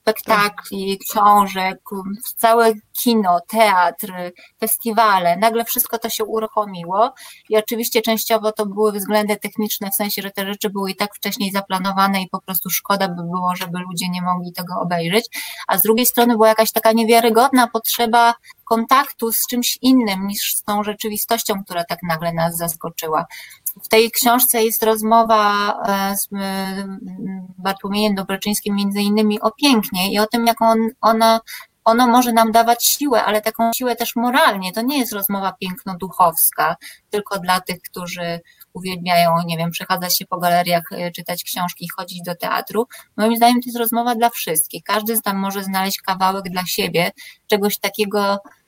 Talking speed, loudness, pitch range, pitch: 155 wpm, -18 LUFS, 190-225 Hz, 210 Hz